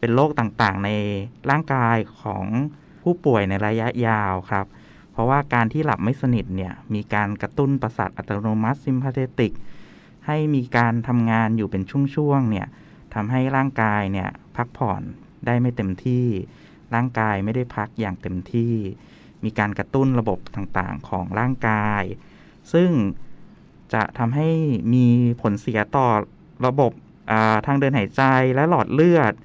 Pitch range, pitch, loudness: 105-135 Hz, 115 Hz, -22 LUFS